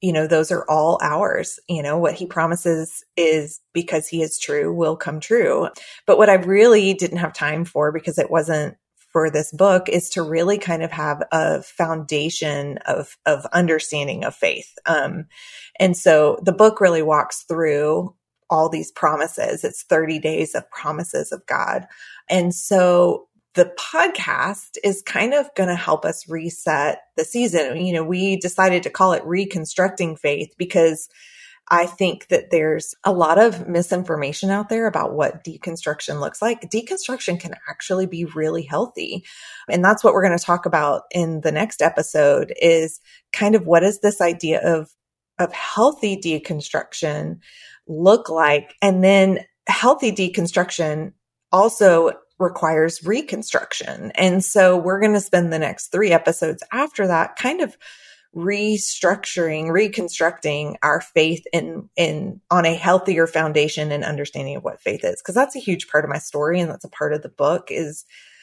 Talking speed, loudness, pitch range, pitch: 165 wpm, -19 LUFS, 160-195 Hz, 175 Hz